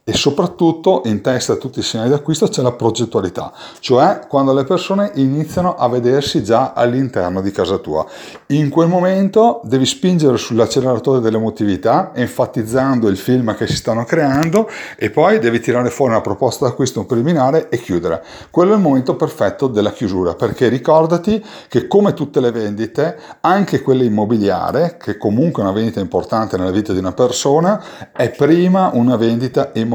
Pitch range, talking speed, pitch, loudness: 115-160 Hz, 165 wpm, 130 Hz, -15 LUFS